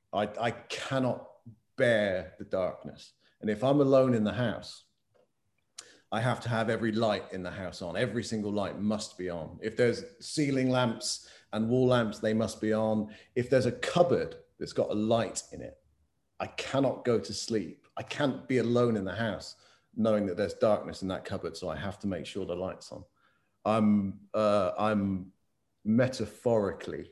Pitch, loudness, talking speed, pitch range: 110 Hz, -30 LUFS, 180 wpm, 100-120 Hz